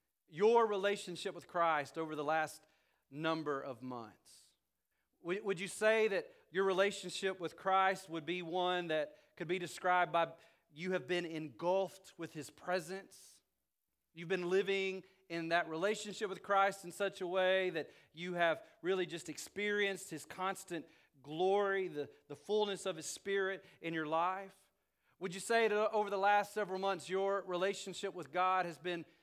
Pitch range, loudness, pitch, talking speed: 165-195 Hz, -37 LUFS, 185 Hz, 160 wpm